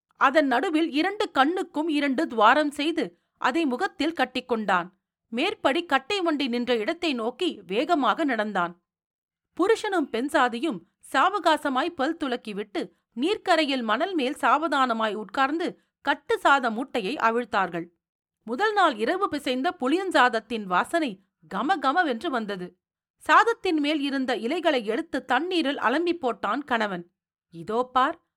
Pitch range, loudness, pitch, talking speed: 230-330 Hz, -25 LUFS, 275 Hz, 110 wpm